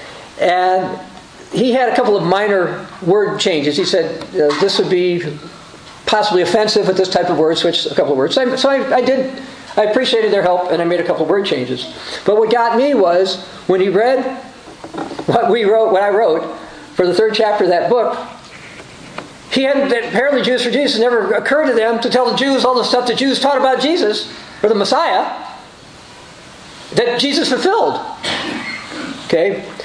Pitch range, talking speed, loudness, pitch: 185-260 Hz, 190 wpm, -15 LUFS, 230 Hz